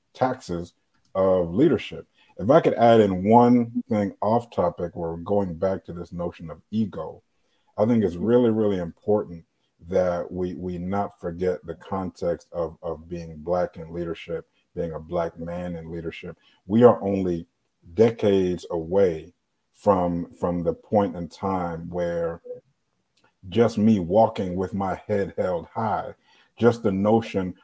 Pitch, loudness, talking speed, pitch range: 90 Hz, -24 LUFS, 150 wpm, 85-105 Hz